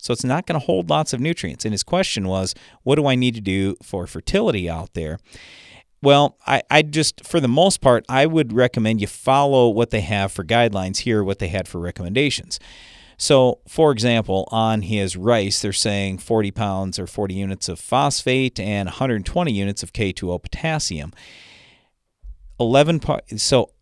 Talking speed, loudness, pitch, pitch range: 180 wpm, -20 LUFS, 110 Hz, 95-130 Hz